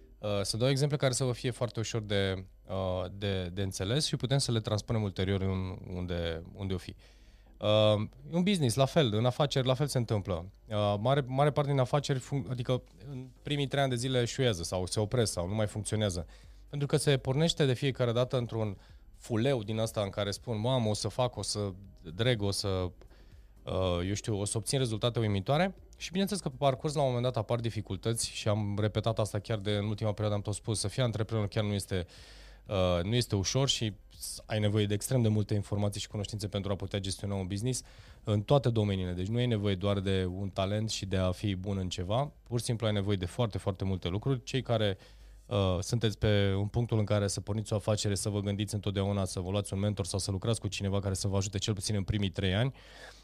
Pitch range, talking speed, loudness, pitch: 100-125 Hz, 225 wpm, -32 LUFS, 105 Hz